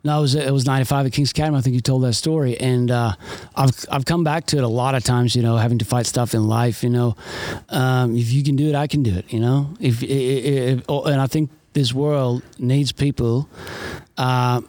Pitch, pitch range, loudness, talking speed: 130 Hz, 120-140 Hz, -20 LUFS, 250 wpm